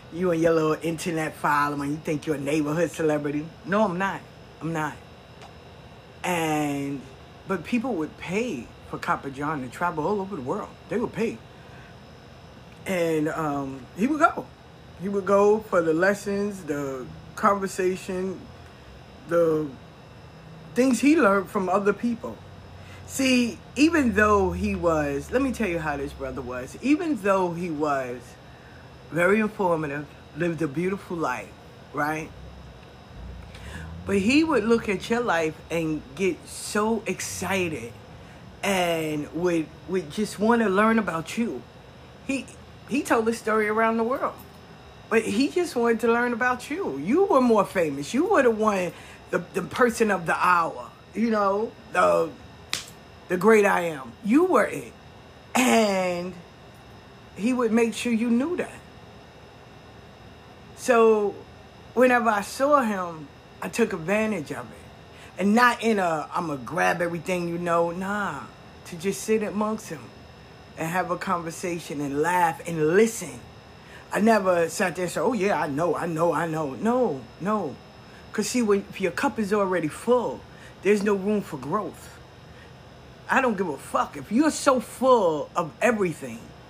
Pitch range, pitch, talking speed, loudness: 155-220 Hz, 185 Hz, 155 wpm, -24 LUFS